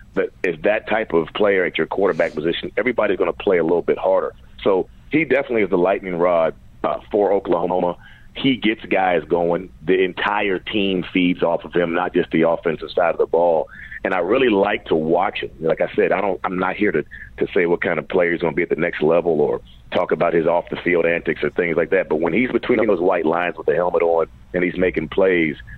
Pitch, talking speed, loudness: 135 Hz, 235 wpm, -19 LUFS